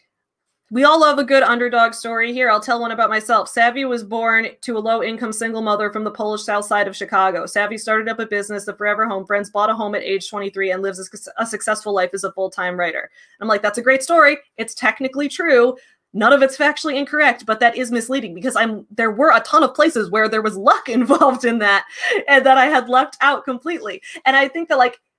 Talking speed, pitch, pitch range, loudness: 230 wpm, 230 Hz, 210-270 Hz, -17 LUFS